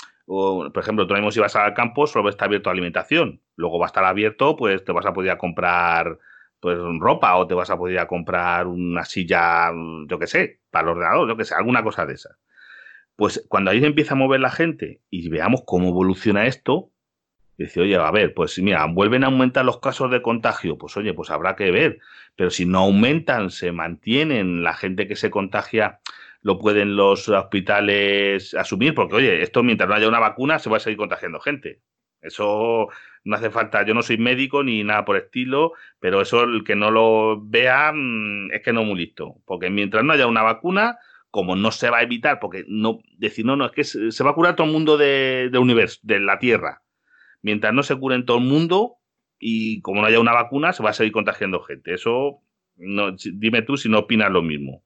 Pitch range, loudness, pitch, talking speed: 95-130 Hz, -20 LUFS, 110 Hz, 220 wpm